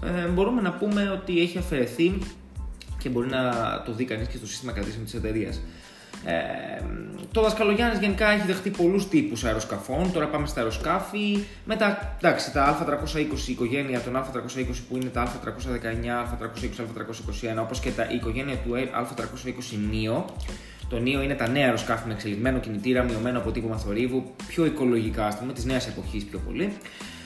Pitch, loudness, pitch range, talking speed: 125 Hz, -27 LUFS, 115-160 Hz, 170 wpm